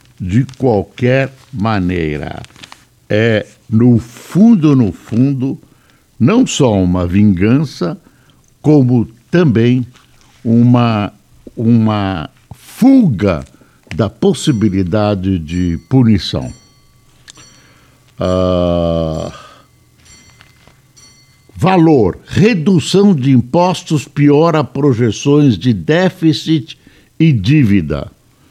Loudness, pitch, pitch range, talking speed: -13 LUFS, 125 Hz, 105-145 Hz, 65 wpm